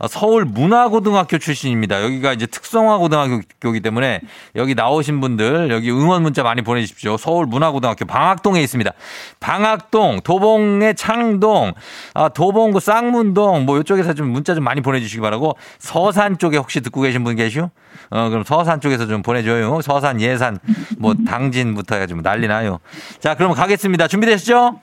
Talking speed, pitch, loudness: 375 characters per minute, 150 Hz, -16 LUFS